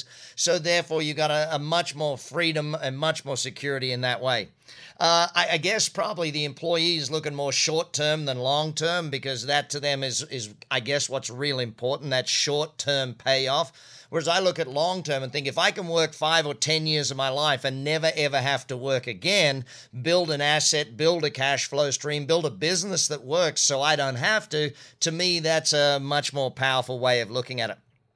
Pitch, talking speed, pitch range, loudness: 145 Hz, 205 wpm, 135-160 Hz, -24 LUFS